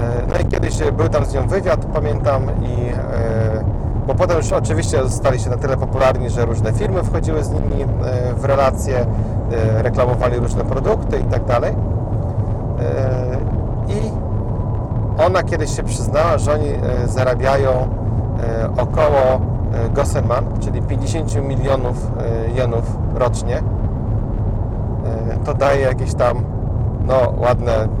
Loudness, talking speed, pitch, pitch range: -18 LUFS, 110 wpm, 110 Hz, 110-120 Hz